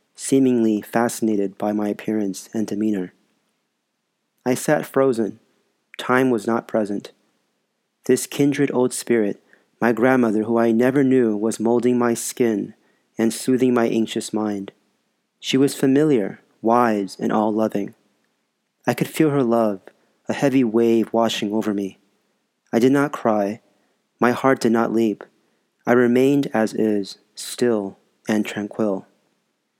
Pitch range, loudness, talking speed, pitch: 105-125 Hz, -20 LUFS, 135 wpm, 115 Hz